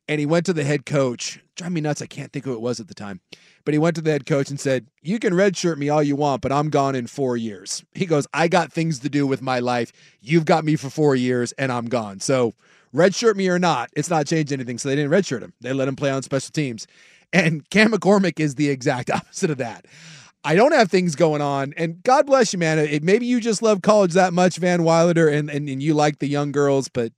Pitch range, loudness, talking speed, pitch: 135-175 Hz, -20 LUFS, 265 wpm, 150 Hz